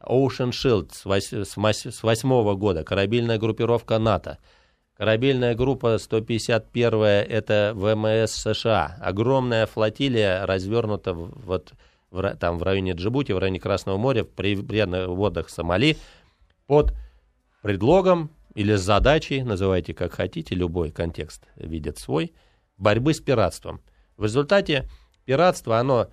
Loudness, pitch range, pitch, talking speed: -23 LUFS, 95-120 Hz, 105 Hz, 115 wpm